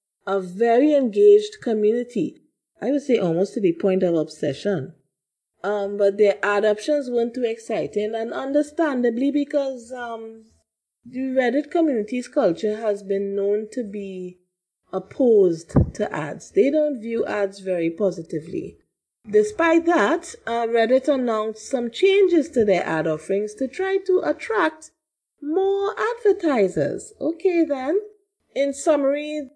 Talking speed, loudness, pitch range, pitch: 130 wpm, -22 LUFS, 200-300 Hz, 240 Hz